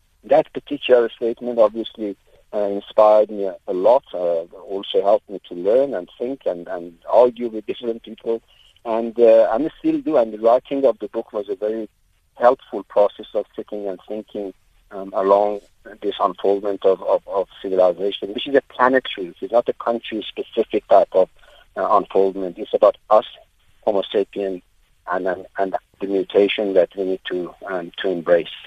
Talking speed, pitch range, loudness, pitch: 165 wpm, 95-115 Hz, -20 LUFS, 105 Hz